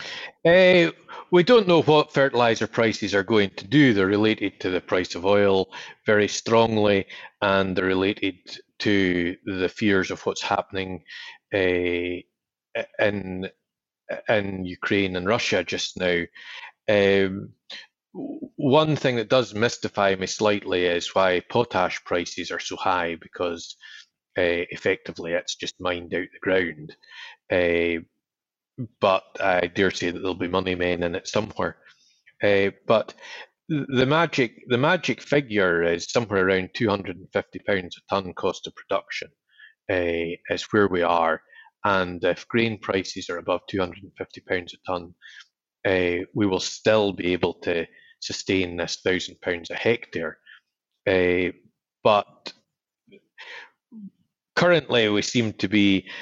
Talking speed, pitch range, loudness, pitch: 130 wpm, 90-120 Hz, -23 LUFS, 100 Hz